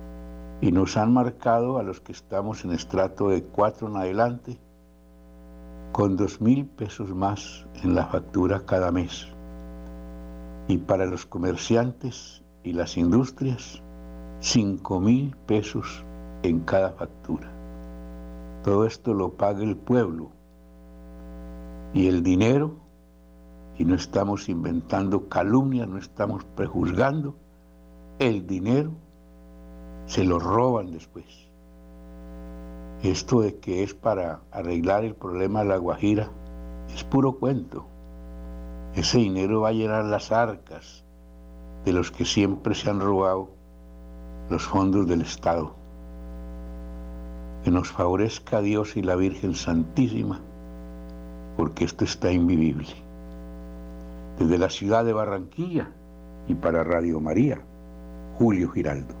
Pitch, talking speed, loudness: 85 Hz, 120 wpm, -25 LUFS